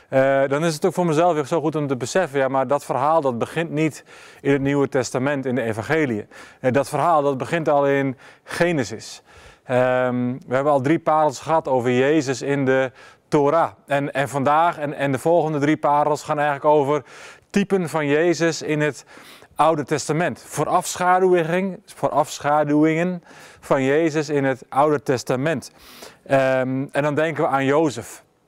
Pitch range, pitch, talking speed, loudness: 135-160 Hz, 145 Hz, 170 wpm, -20 LUFS